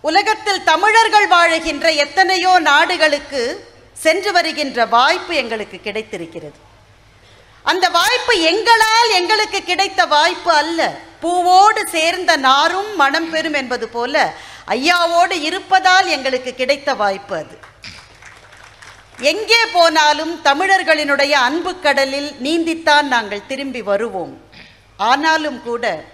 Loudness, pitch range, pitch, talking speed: -14 LUFS, 250-360 Hz, 315 Hz, 95 wpm